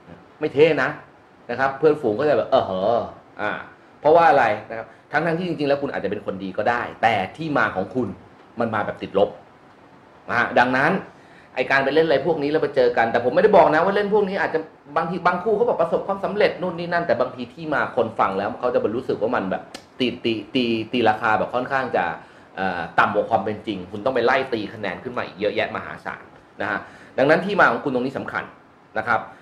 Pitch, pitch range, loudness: 140 Hz, 115-175 Hz, -21 LUFS